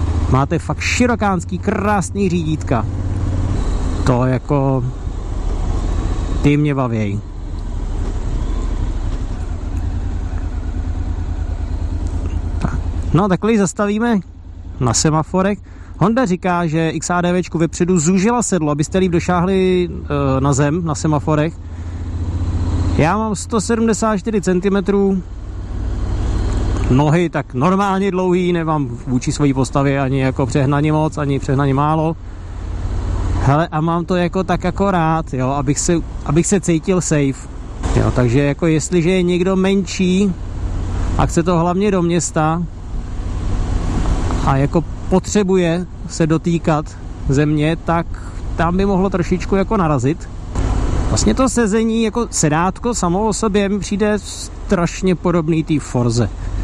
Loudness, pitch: -17 LUFS, 145 Hz